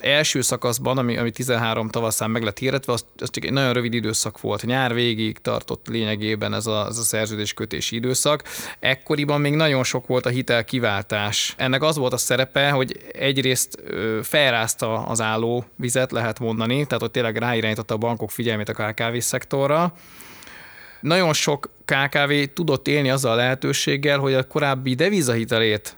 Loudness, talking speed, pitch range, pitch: -21 LUFS, 160 wpm, 115-135 Hz, 125 Hz